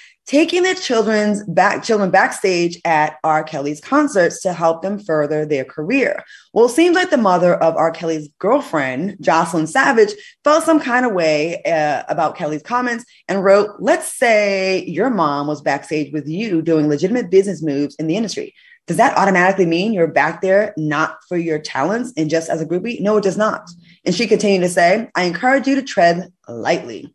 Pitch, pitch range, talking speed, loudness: 185 Hz, 160-235 Hz, 190 wpm, -17 LUFS